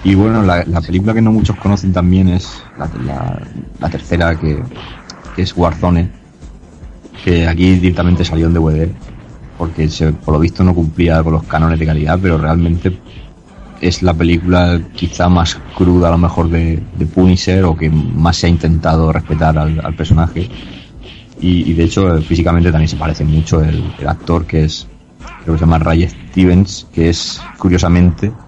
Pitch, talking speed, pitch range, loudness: 85 Hz, 175 wpm, 80-90 Hz, -13 LUFS